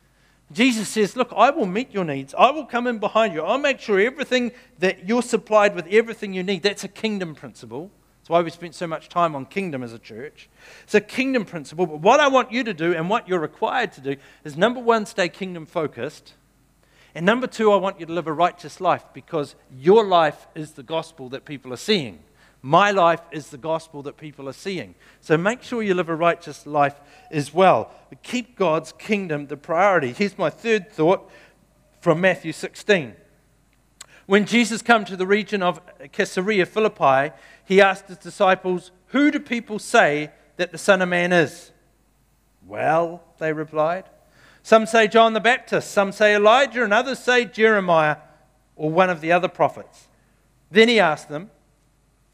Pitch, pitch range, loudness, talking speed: 185 Hz, 155-215 Hz, -20 LUFS, 190 wpm